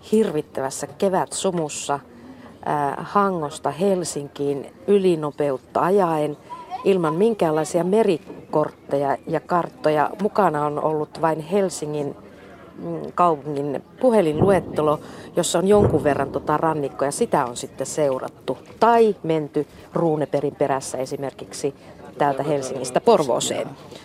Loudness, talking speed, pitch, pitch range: -22 LUFS, 95 wpm, 155 Hz, 145-180 Hz